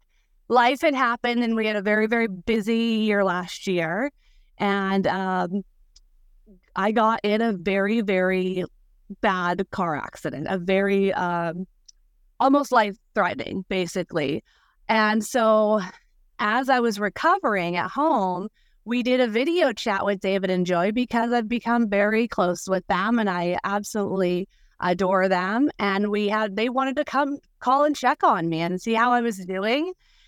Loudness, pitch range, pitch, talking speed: -23 LUFS, 185-235 Hz, 210 Hz, 155 wpm